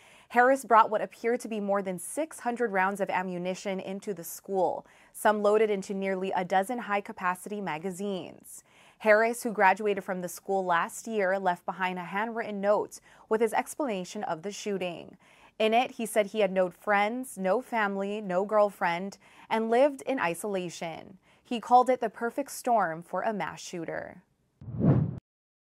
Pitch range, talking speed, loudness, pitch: 190-225 Hz, 160 wpm, -29 LUFS, 205 Hz